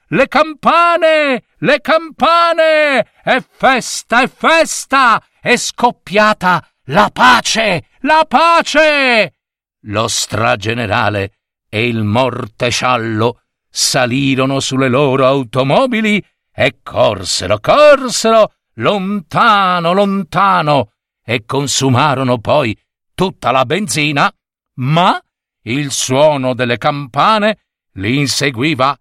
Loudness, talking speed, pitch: -12 LUFS, 85 wpm, 155 Hz